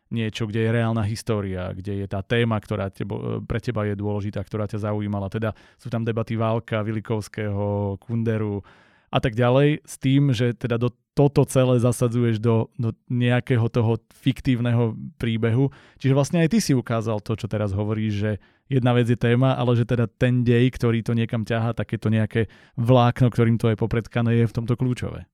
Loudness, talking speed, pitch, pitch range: -23 LUFS, 180 wpm, 115 Hz, 110-125 Hz